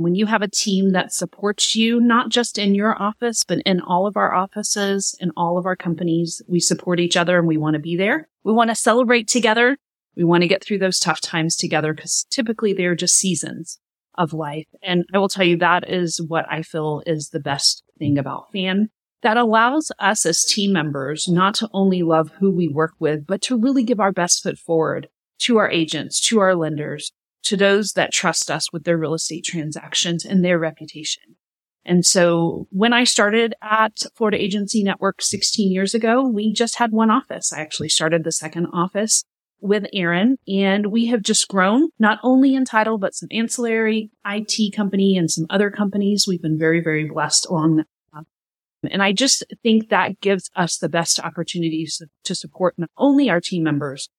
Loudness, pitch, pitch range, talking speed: -19 LUFS, 185 Hz, 165-215 Hz, 200 wpm